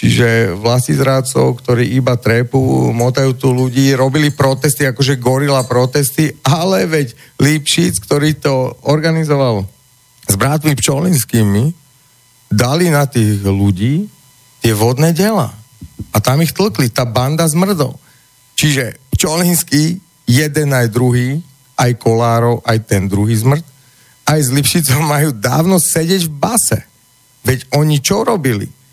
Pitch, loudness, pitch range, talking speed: 135 Hz, -13 LUFS, 125-150 Hz, 125 wpm